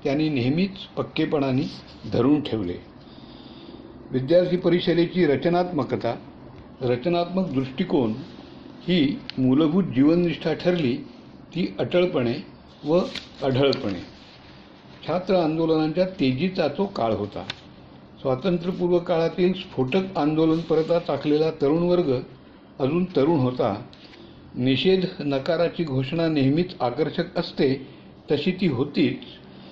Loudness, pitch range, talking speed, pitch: -23 LUFS, 130-175 Hz, 90 wpm, 160 Hz